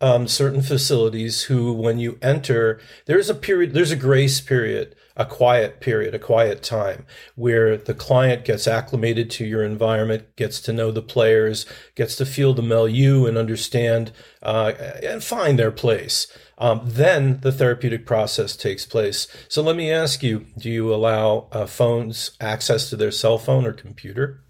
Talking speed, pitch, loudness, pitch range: 165 wpm, 120 Hz, -20 LUFS, 110-135 Hz